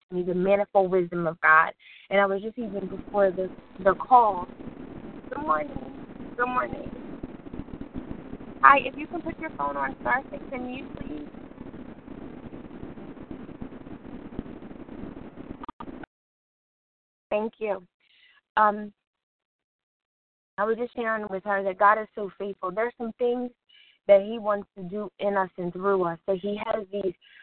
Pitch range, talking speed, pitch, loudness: 195-260 Hz, 135 wpm, 215 Hz, -26 LUFS